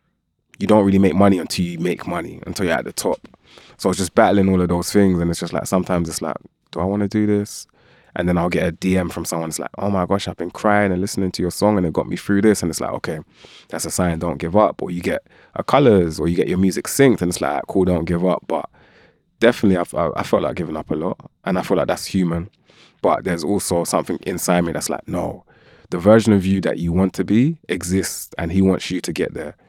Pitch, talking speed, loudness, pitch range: 90 Hz, 265 wpm, -19 LUFS, 85-100 Hz